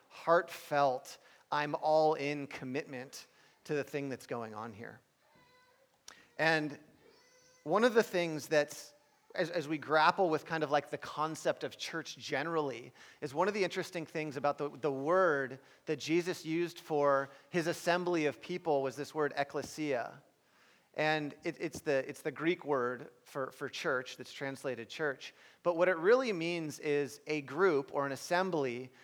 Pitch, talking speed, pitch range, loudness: 150 Hz, 160 wpm, 140-170 Hz, -34 LUFS